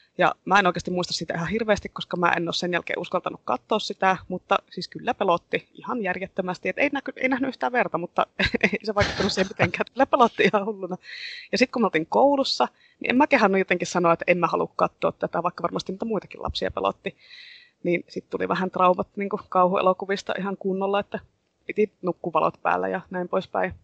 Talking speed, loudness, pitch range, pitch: 205 wpm, -24 LUFS, 180-225 Hz, 195 Hz